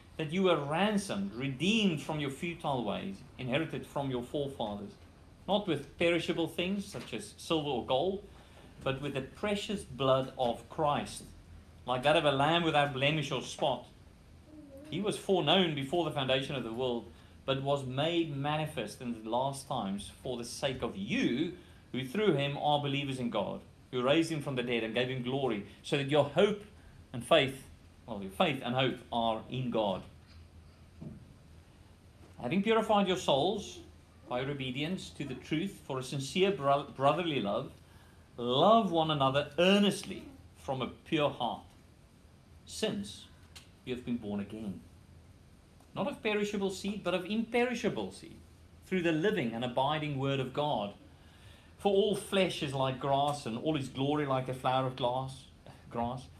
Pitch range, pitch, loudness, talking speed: 120-170 Hz, 135 Hz, -32 LUFS, 165 wpm